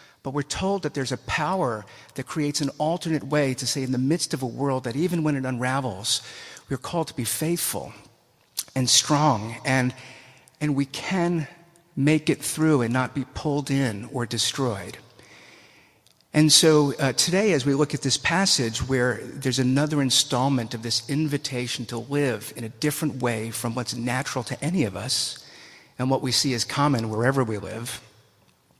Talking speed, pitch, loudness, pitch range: 180 wpm, 135 Hz, -24 LUFS, 125-150 Hz